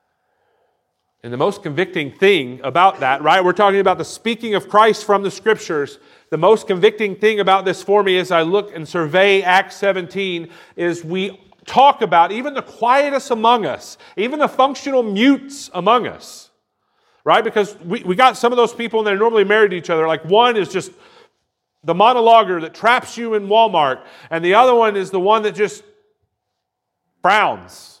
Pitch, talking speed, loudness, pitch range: 210 Hz, 180 wpm, -16 LUFS, 185-235 Hz